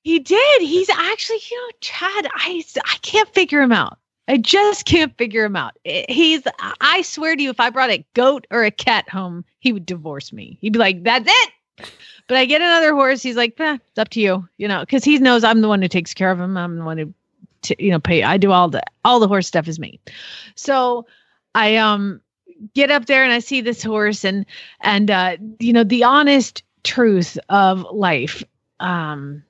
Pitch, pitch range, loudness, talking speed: 235 Hz, 195-290 Hz, -16 LUFS, 220 wpm